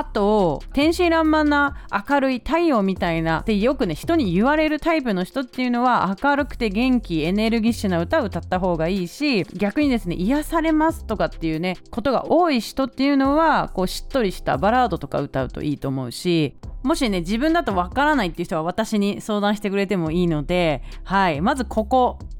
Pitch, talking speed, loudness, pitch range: 220 Hz, 410 characters per minute, -21 LUFS, 180-280 Hz